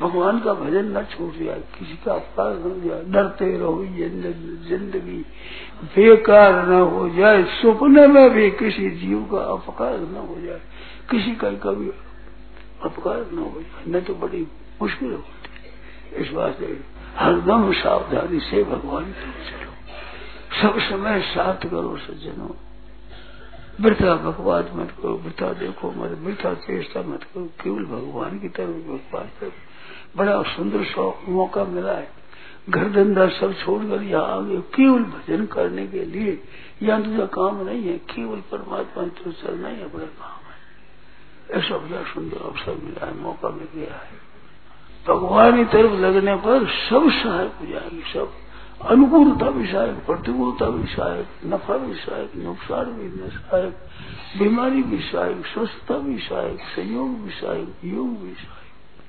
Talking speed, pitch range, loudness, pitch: 135 wpm, 180-235 Hz, -20 LUFS, 200 Hz